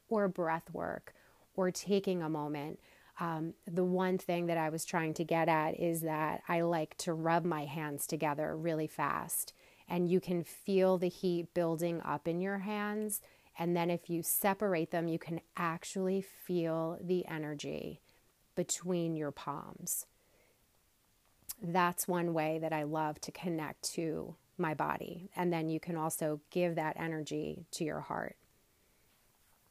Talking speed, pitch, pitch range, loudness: 155 wpm, 170 Hz, 155-180 Hz, -36 LUFS